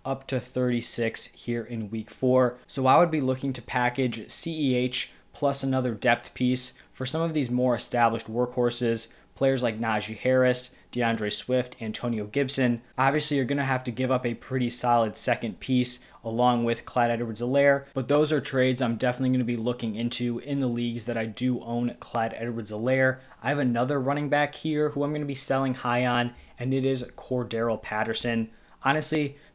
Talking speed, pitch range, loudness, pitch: 190 wpm, 120-135 Hz, -27 LUFS, 125 Hz